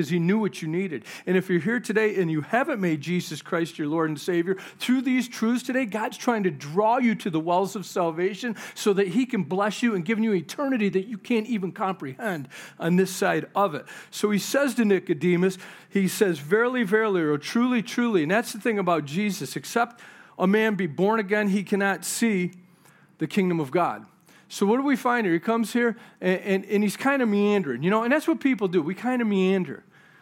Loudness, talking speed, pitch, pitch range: -25 LUFS, 220 wpm, 200 Hz, 180-230 Hz